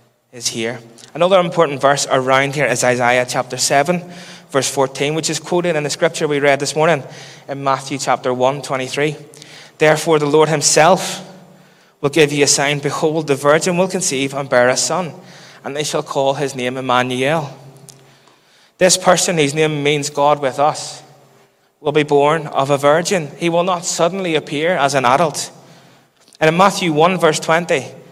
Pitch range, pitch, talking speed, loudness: 135-165 Hz, 150 Hz, 175 wpm, -16 LUFS